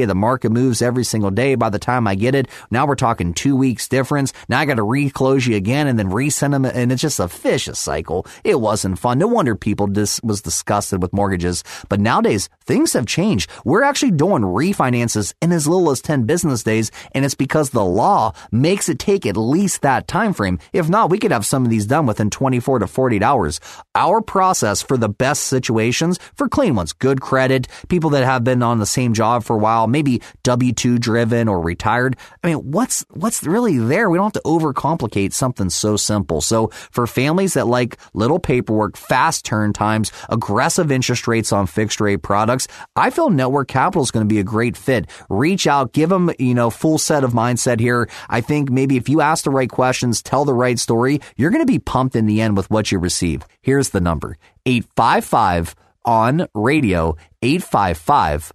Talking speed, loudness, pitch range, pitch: 210 wpm, -17 LUFS, 105-140 Hz, 125 Hz